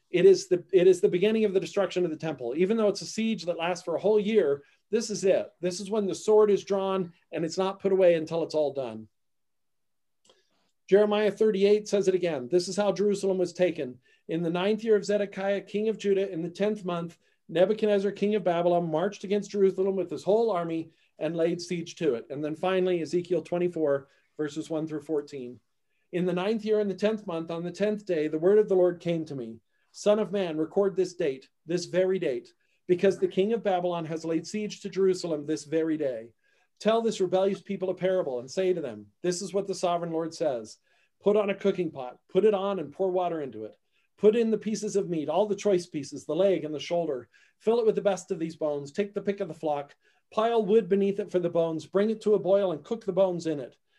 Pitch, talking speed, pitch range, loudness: 185 Hz, 235 wpm, 165-200 Hz, -27 LUFS